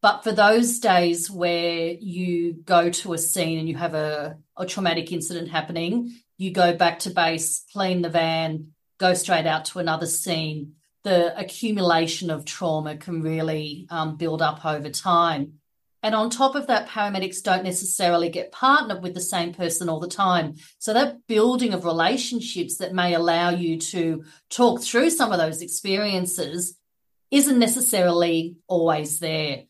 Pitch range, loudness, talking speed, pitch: 165-195 Hz, -23 LUFS, 160 wpm, 175 Hz